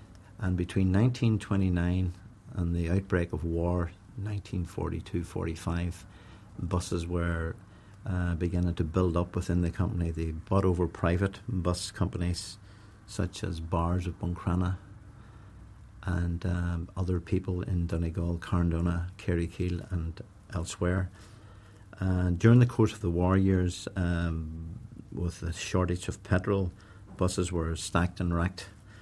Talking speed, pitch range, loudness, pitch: 125 wpm, 85-100 Hz, -30 LUFS, 90 Hz